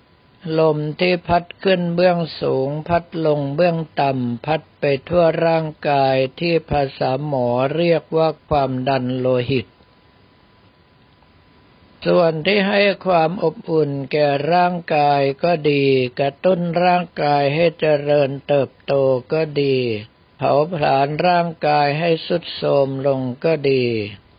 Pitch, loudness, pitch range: 150 Hz, -18 LUFS, 135-170 Hz